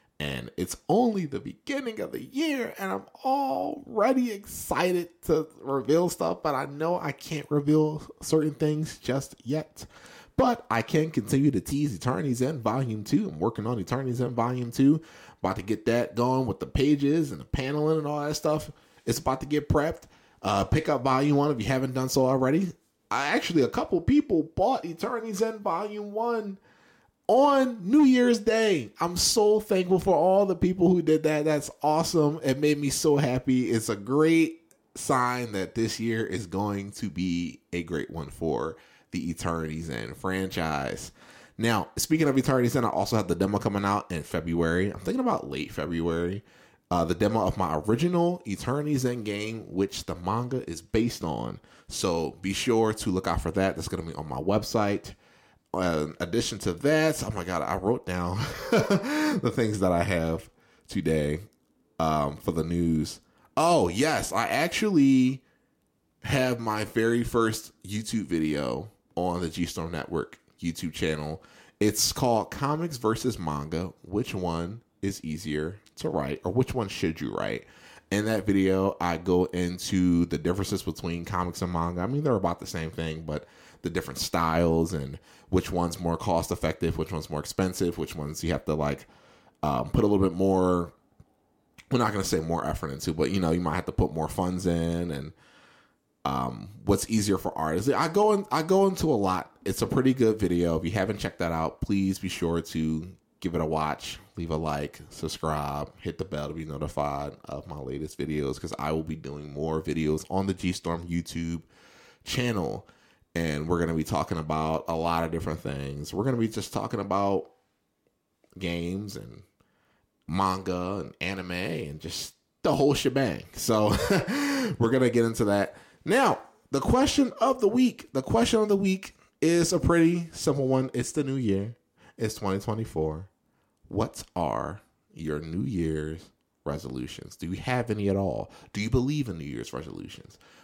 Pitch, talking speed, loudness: 100 Hz, 180 wpm, -27 LUFS